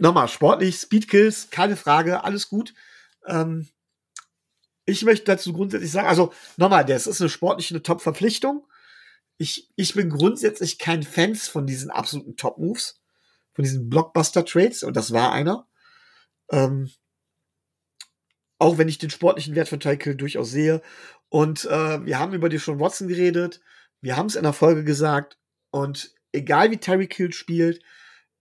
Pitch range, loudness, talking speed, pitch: 145-190 Hz, -22 LUFS, 150 wpm, 165 Hz